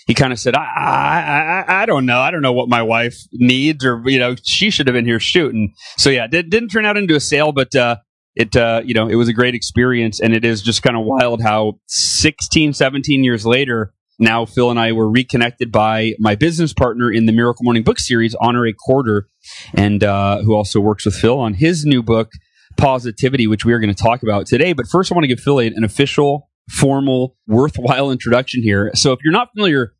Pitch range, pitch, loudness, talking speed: 115-135 Hz, 120 Hz, -15 LUFS, 230 wpm